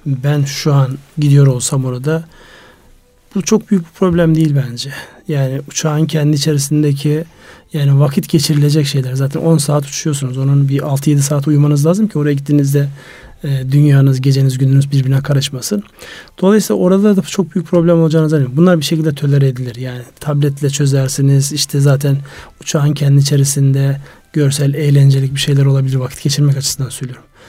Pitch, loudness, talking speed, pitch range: 145 Hz, -13 LUFS, 155 wpm, 135-155 Hz